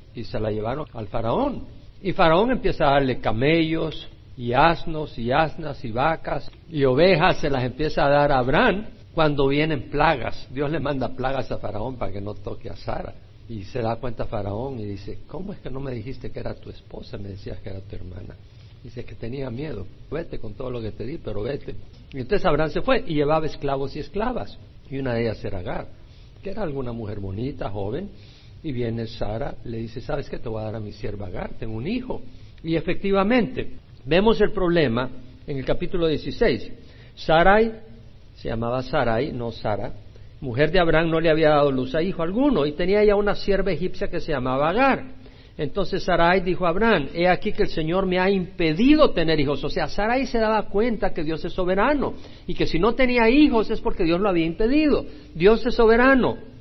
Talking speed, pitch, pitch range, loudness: 205 wpm, 145 Hz, 115-180 Hz, -23 LUFS